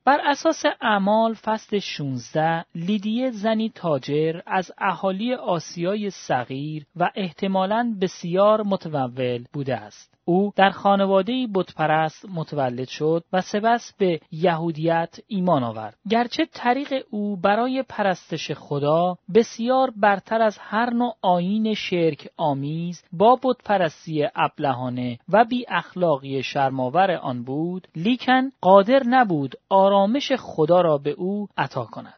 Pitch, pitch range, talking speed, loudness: 185 Hz, 155-220 Hz, 115 wpm, -22 LUFS